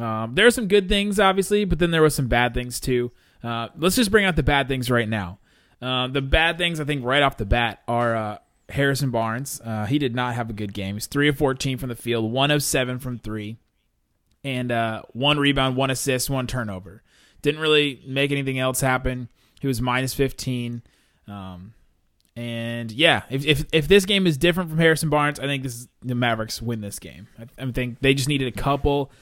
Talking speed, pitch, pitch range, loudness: 220 wpm, 130 Hz, 115-145 Hz, -22 LUFS